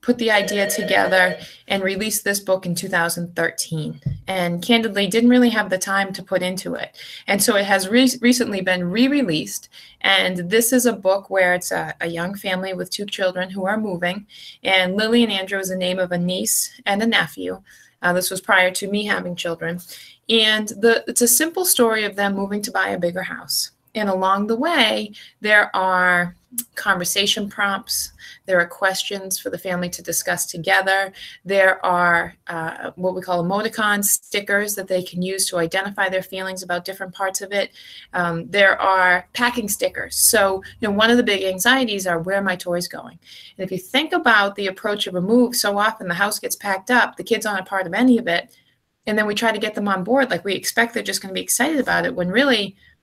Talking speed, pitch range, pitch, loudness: 210 wpm, 180-215 Hz, 195 Hz, -19 LUFS